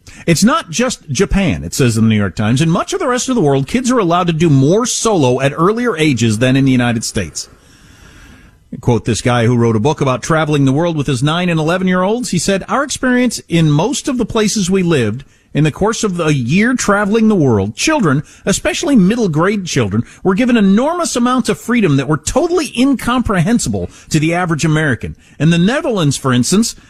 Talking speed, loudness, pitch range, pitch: 210 wpm, -14 LUFS, 135-225 Hz, 170 Hz